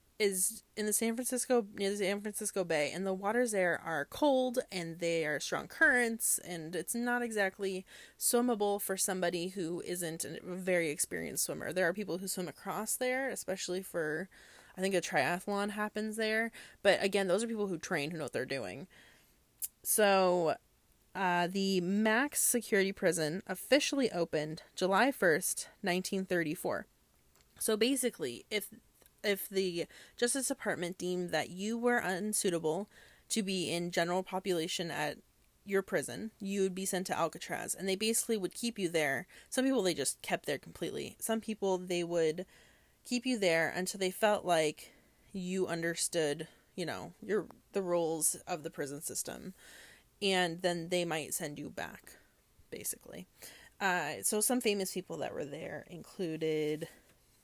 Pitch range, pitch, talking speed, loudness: 175-215 Hz, 190 Hz, 160 wpm, -34 LUFS